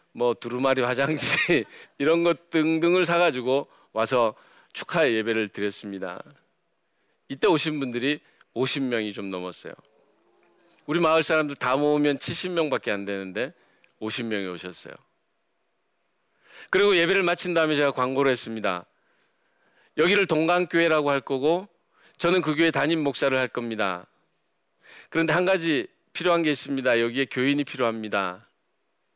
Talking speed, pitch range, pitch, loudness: 285 characters per minute, 120-170 Hz, 145 Hz, -24 LUFS